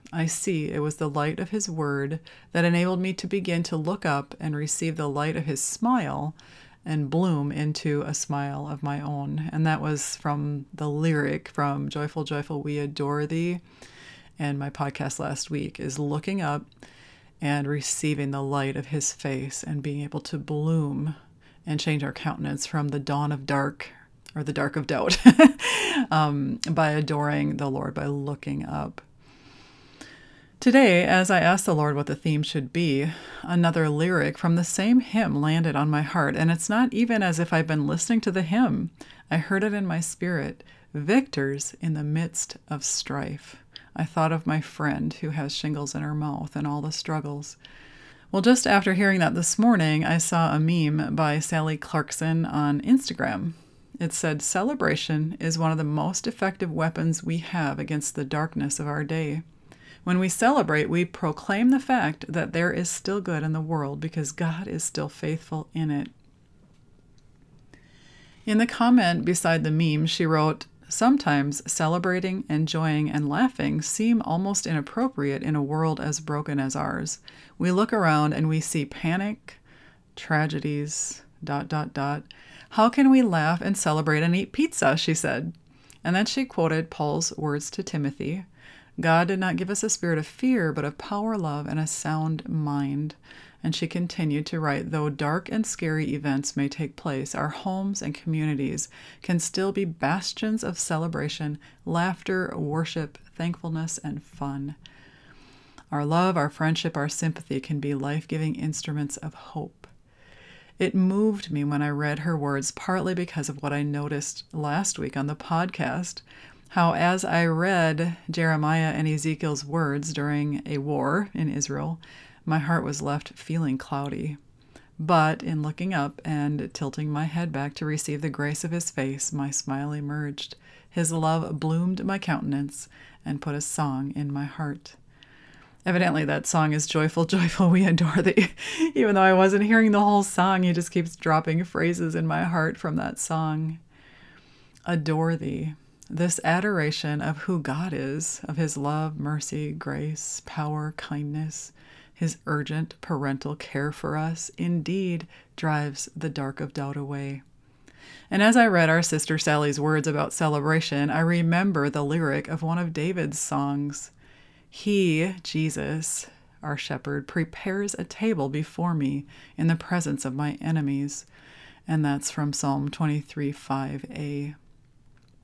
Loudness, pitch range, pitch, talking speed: -25 LUFS, 145-170 Hz, 155 Hz, 165 wpm